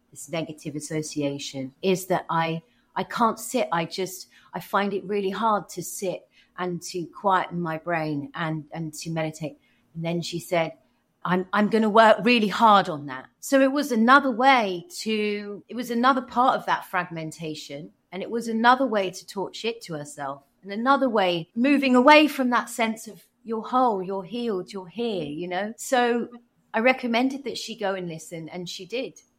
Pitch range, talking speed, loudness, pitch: 165-230 Hz, 185 wpm, -24 LUFS, 190 Hz